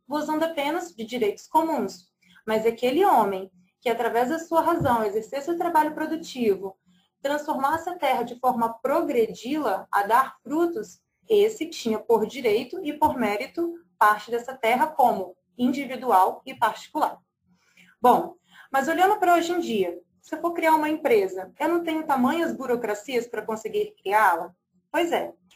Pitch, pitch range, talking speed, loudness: 265 Hz, 220-320 Hz, 150 wpm, -24 LUFS